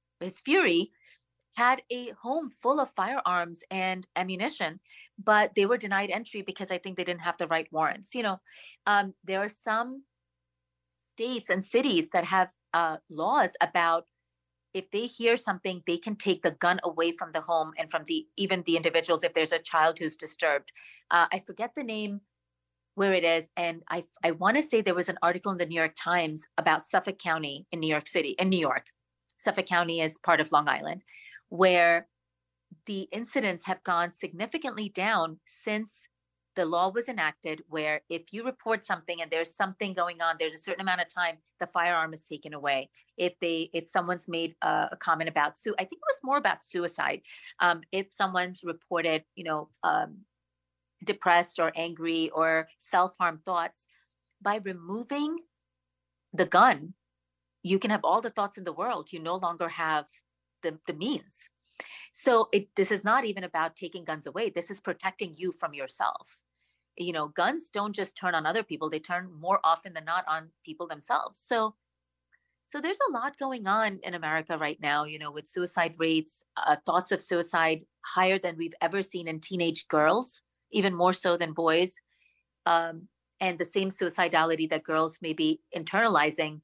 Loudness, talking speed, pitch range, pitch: -29 LUFS, 180 wpm, 160-200 Hz, 175 Hz